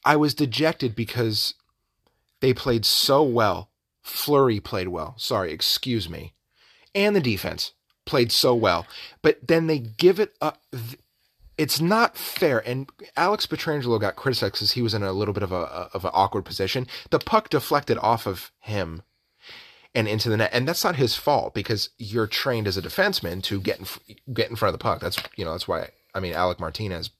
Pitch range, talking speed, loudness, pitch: 105-150 Hz, 190 wpm, -24 LUFS, 115 Hz